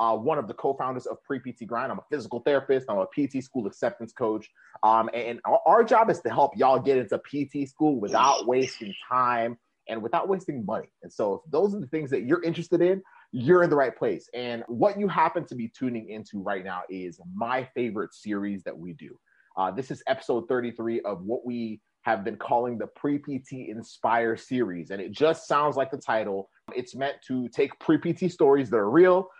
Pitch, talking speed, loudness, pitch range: 125 Hz, 220 wpm, -26 LUFS, 115-150 Hz